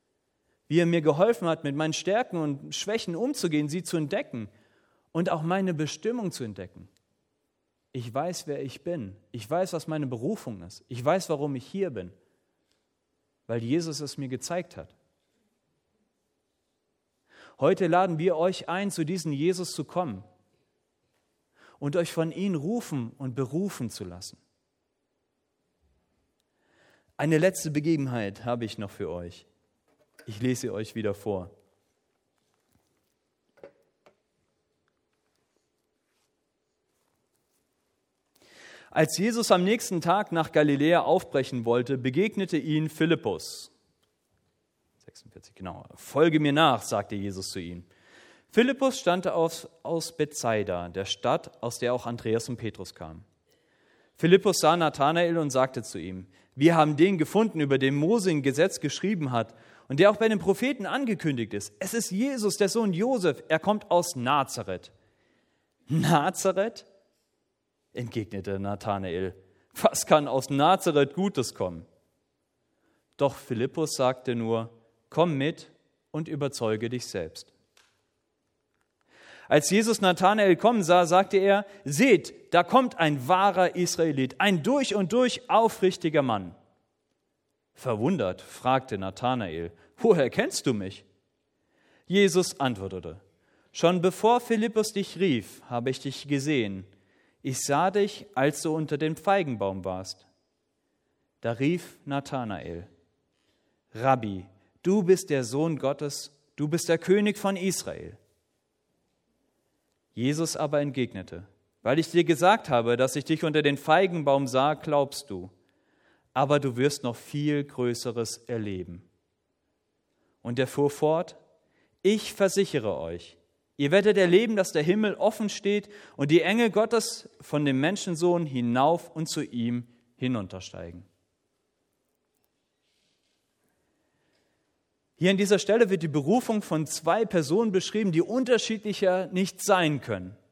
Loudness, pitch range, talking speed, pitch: -26 LUFS, 120-185 Hz, 125 wpm, 150 Hz